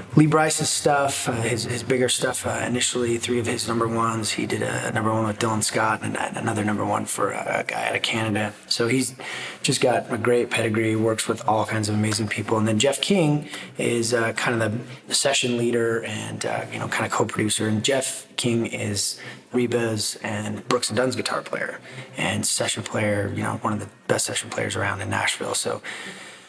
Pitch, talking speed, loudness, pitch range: 115 Hz, 205 wpm, -23 LUFS, 110-125 Hz